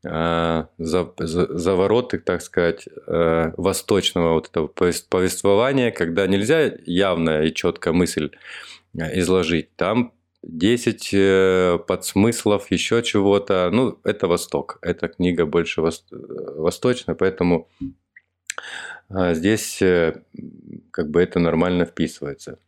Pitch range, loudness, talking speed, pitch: 85-95 Hz, -20 LUFS, 85 wpm, 90 Hz